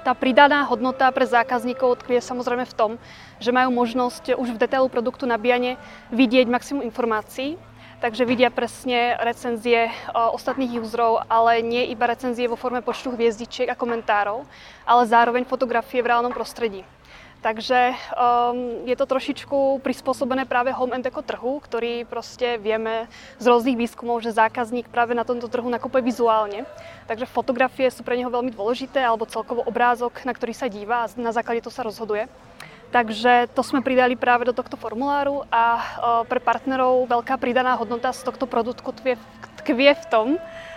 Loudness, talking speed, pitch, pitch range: -22 LUFS, 160 wpm, 245 Hz, 235-255 Hz